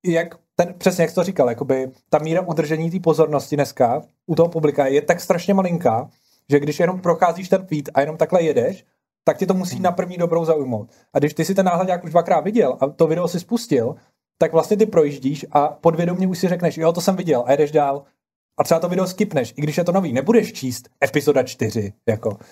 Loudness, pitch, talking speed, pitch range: -20 LUFS, 165 Hz, 225 wpm, 145-180 Hz